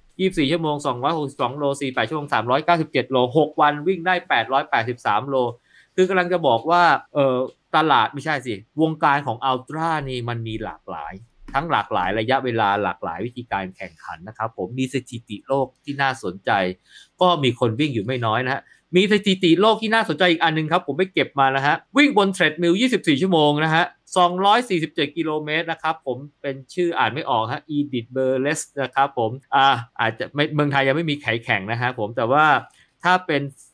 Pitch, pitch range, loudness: 140 Hz, 125-165 Hz, -21 LUFS